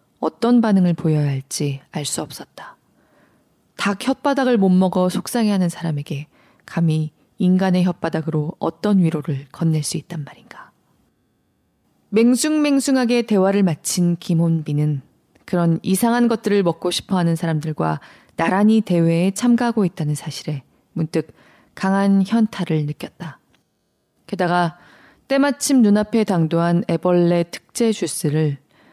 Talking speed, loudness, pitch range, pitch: 280 characters per minute, -19 LUFS, 160-205 Hz, 175 Hz